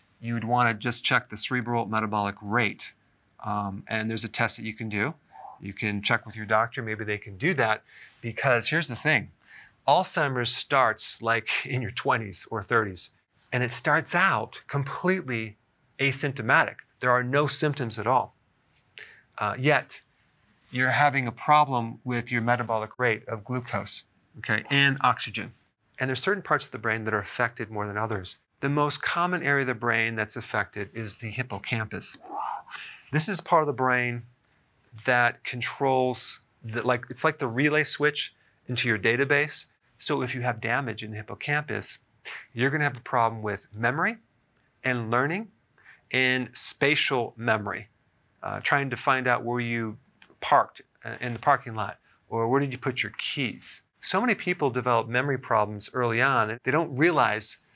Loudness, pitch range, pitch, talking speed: -26 LUFS, 110-140 Hz, 120 Hz, 170 wpm